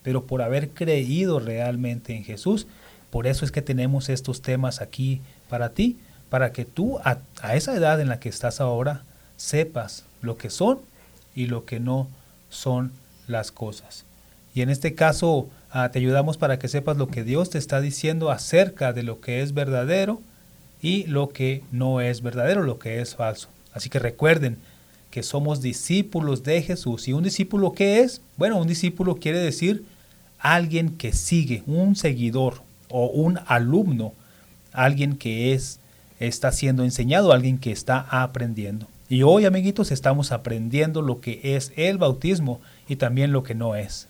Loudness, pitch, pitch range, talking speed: -23 LUFS, 130 Hz, 120-155 Hz, 170 wpm